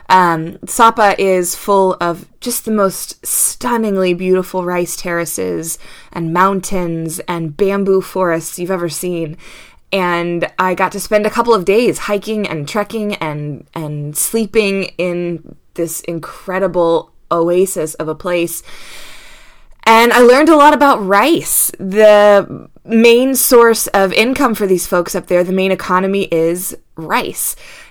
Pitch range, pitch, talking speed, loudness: 170-210 Hz, 185 Hz, 140 wpm, -13 LUFS